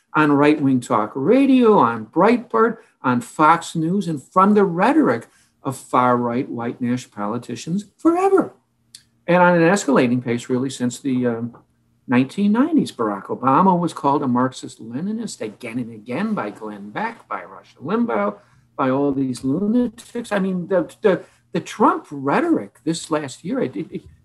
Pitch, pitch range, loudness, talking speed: 140 Hz, 125-200 Hz, -19 LUFS, 150 wpm